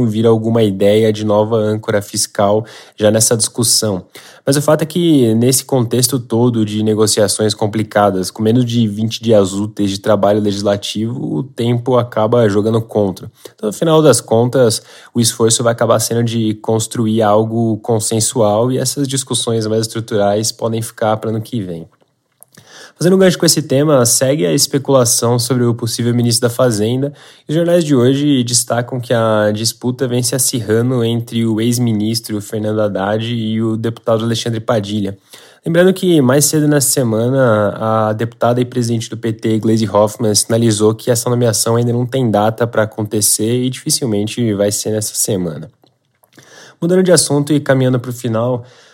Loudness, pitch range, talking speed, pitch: -14 LUFS, 110-125 Hz, 165 wpm, 115 Hz